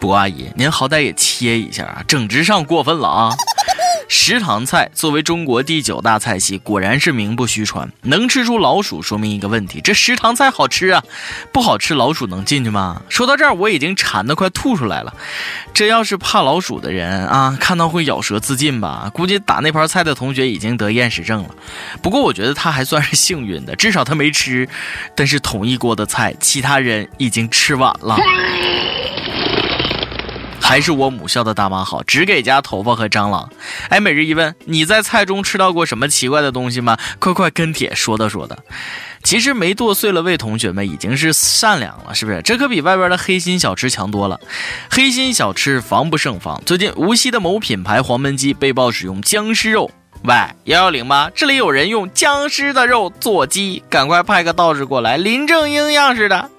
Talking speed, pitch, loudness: 295 characters per minute, 145 Hz, -14 LUFS